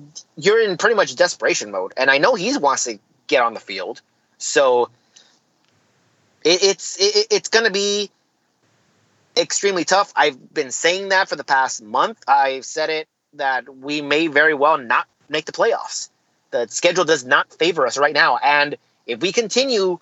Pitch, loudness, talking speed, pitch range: 185 Hz, -18 LUFS, 170 wpm, 150-225 Hz